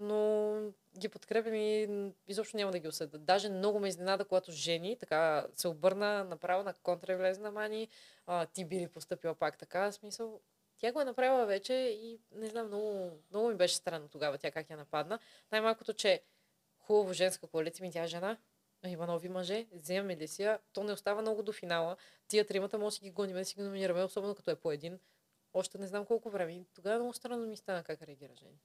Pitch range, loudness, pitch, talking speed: 180-215 Hz, -36 LUFS, 195 Hz, 195 wpm